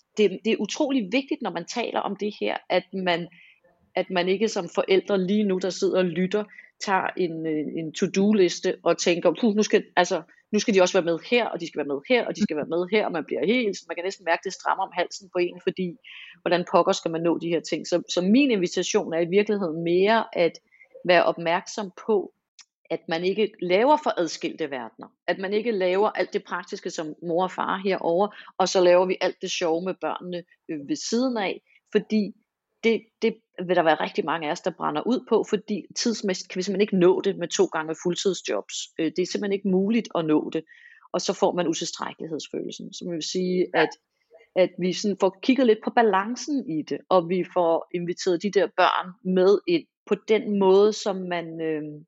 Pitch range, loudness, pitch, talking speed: 175-210 Hz, -24 LUFS, 185 Hz, 220 wpm